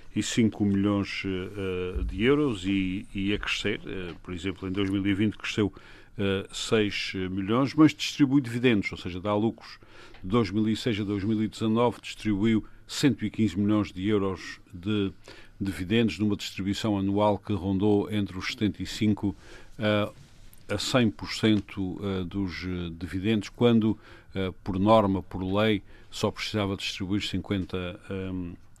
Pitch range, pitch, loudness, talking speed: 95-110 Hz, 105 Hz, -27 LUFS, 125 wpm